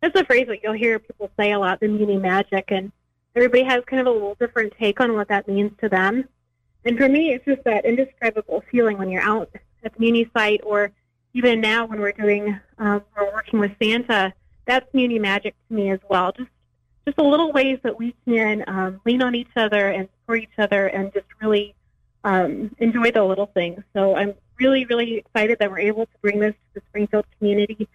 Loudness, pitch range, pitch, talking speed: -21 LUFS, 200-235 Hz, 215 Hz, 215 wpm